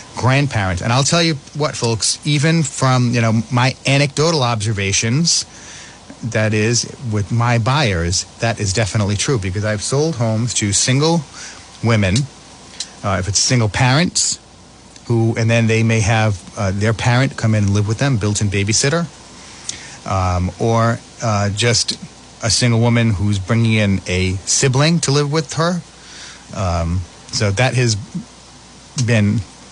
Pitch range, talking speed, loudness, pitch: 105-130 Hz, 145 wpm, -16 LUFS, 115 Hz